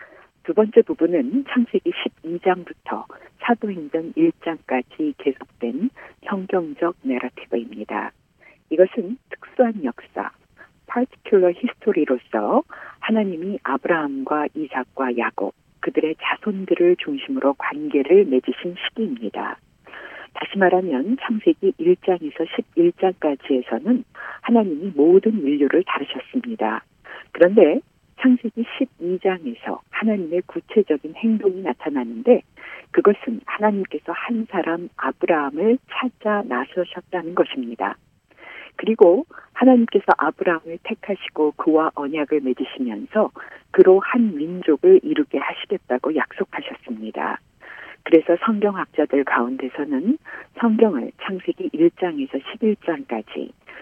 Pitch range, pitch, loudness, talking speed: 155-245 Hz, 190 Hz, -21 LUFS, 270 characters per minute